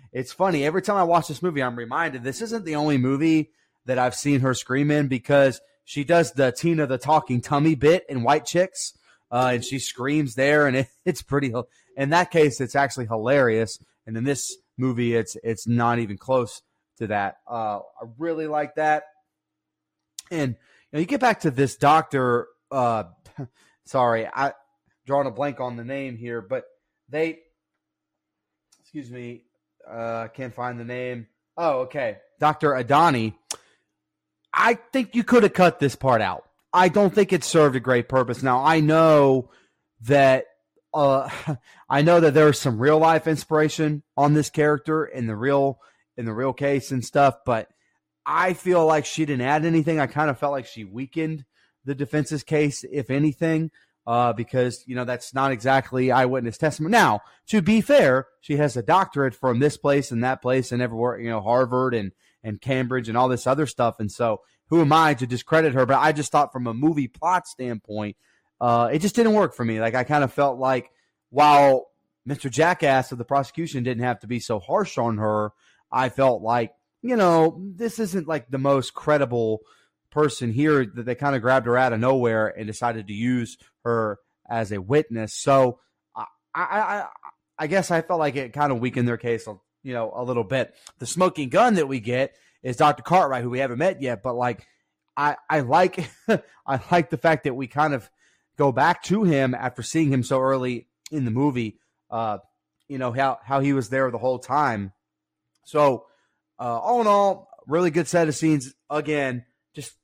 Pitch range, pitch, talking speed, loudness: 125-155 Hz, 135 Hz, 190 wpm, -22 LUFS